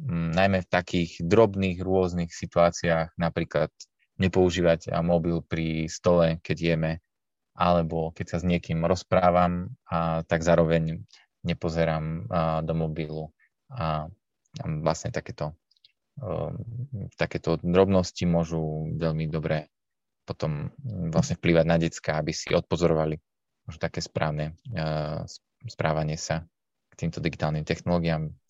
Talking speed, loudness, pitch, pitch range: 115 wpm, -26 LUFS, 85 Hz, 80-90 Hz